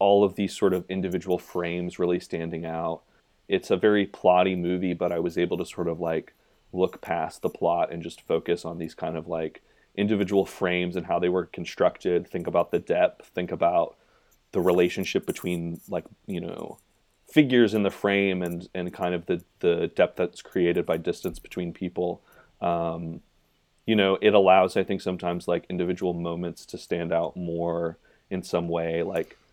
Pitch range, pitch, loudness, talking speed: 85-95 Hz, 90 Hz, -26 LUFS, 185 wpm